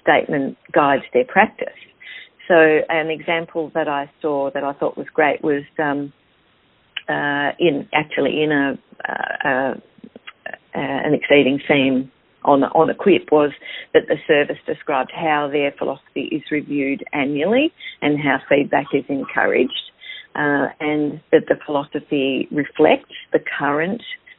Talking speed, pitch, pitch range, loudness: 140 wpm, 150 Hz, 140-160 Hz, -19 LUFS